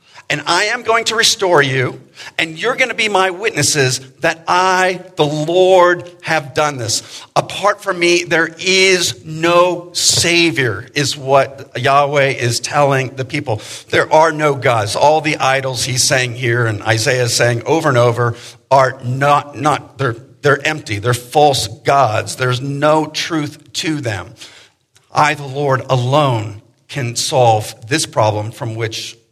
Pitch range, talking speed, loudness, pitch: 120-160 Hz, 155 wpm, -14 LUFS, 140 Hz